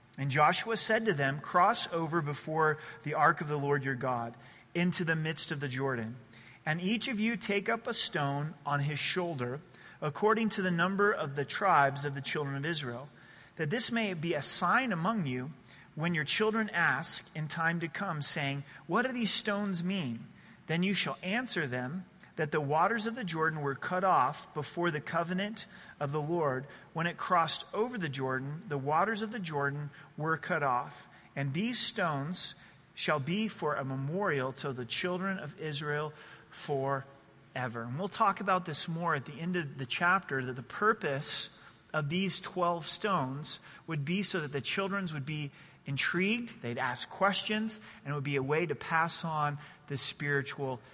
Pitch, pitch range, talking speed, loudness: 160 Hz, 140-185 Hz, 185 wpm, -32 LUFS